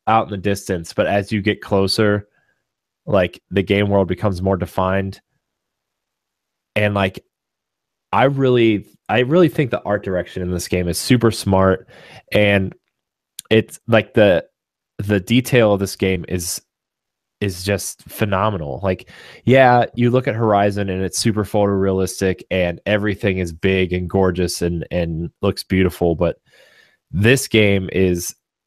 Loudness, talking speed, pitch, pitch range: -18 LUFS, 145 wpm, 100 Hz, 95-105 Hz